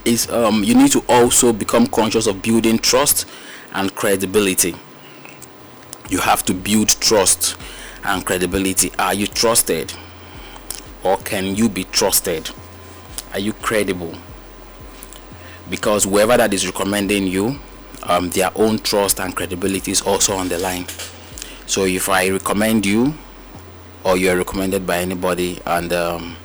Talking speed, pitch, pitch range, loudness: 135 wpm, 95 Hz, 90-110 Hz, -17 LUFS